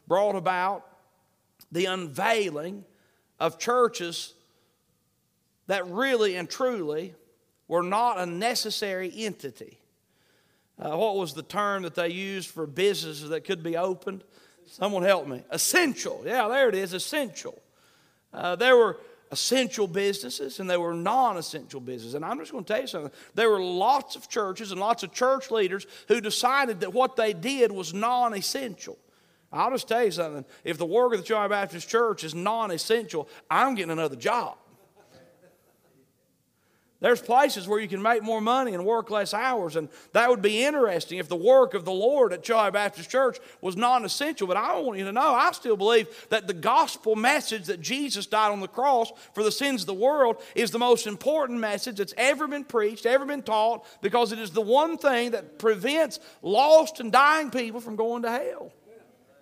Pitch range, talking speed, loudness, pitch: 185-250 Hz, 180 wpm, -25 LUFS, 215 Hz